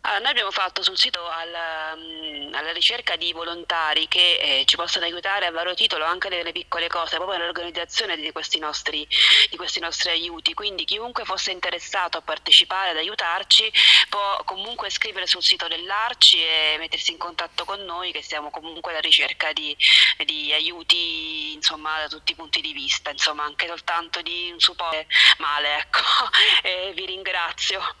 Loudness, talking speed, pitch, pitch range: -20 LUFS, 165 wpm, 170 Hz, 155-175 Hz